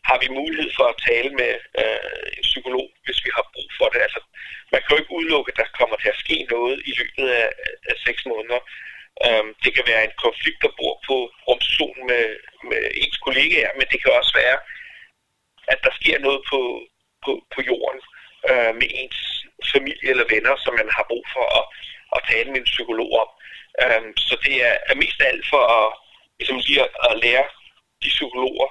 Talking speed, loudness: 195 wpm, -19 LUFS